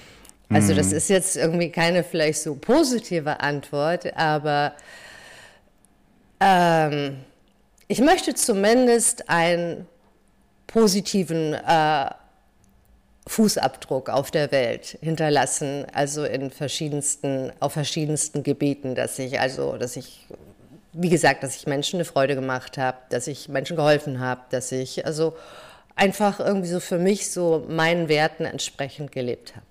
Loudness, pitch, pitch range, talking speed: -22 LUFS, 155 Hz, 140-175 Hz, 125 wpm